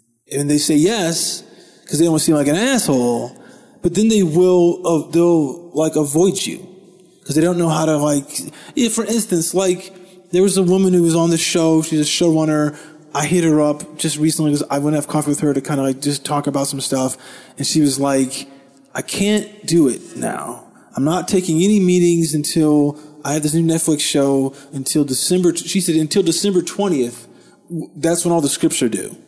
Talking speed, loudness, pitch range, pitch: 205 wpm, -16 LUFS, 145-180 Hz, 160 Hz